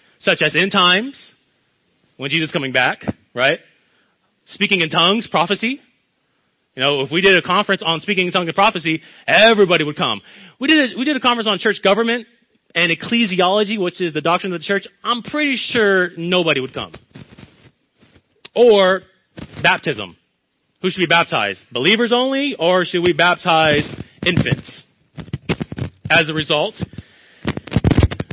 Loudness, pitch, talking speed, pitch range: -16 LUFS, 185 Hz, 150 wpm, 165-220 Hz